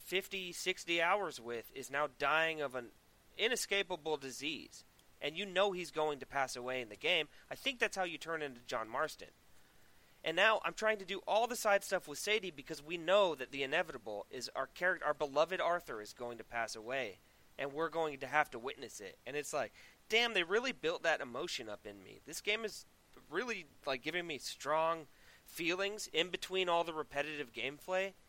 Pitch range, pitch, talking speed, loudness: 145-195 Hz, 165 Hz, 200 wpm, -37 LUFS